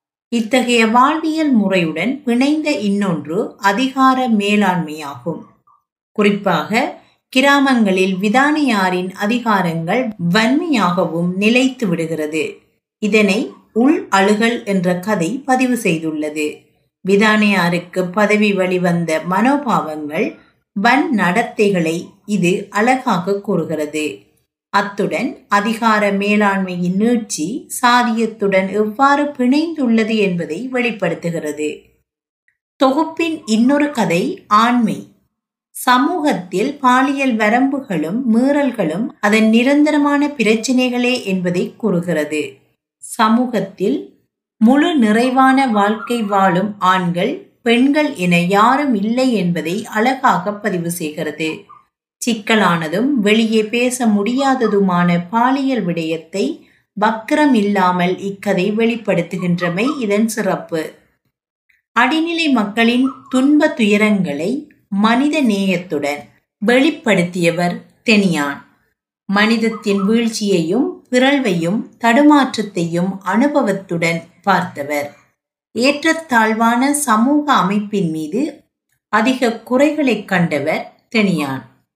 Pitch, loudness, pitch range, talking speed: 215 Hz, -16 LUFS, 185-250 Hz, 75 wpm